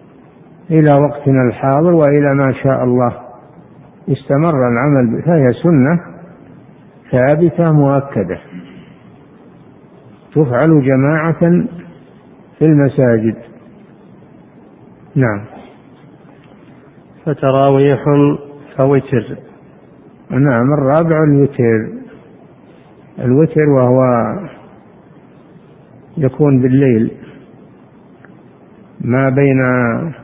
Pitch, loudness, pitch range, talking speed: 140 Hz, -13 LUFS, 130-155 Hz, 60 wpm